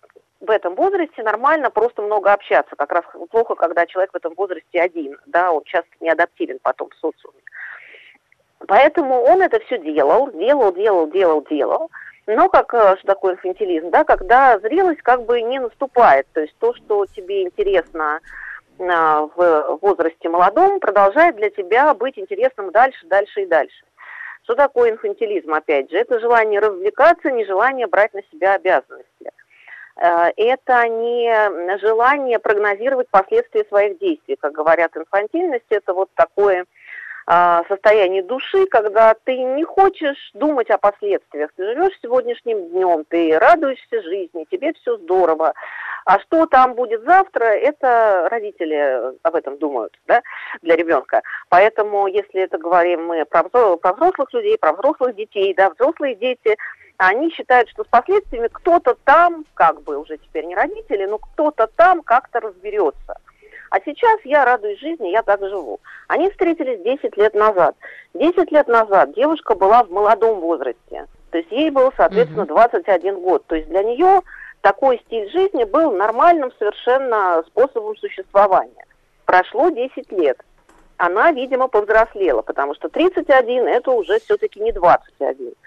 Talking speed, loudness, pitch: 145 wpm, -17 LUFS, 245 Hz